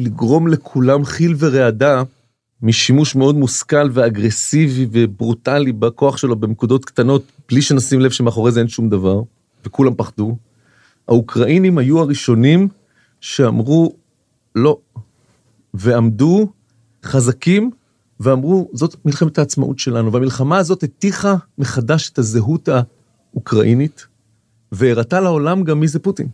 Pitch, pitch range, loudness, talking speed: 130 Hz, 120-150 Hz, -15 LUFS, 110 wpm